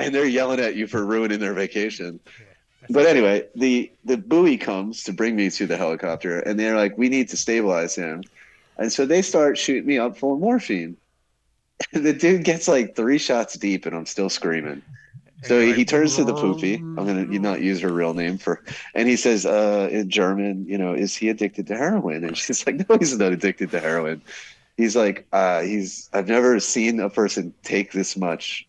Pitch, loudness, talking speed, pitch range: 110 Hz, -21 LUFS, 210 wpm, 95-125 Hz